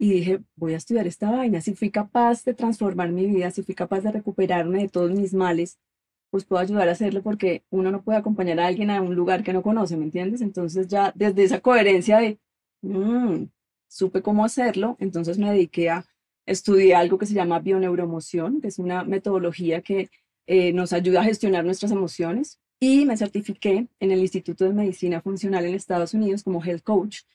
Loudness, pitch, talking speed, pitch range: -23 LUFS, 190 Hz, 195 wpm, 180-210 Hz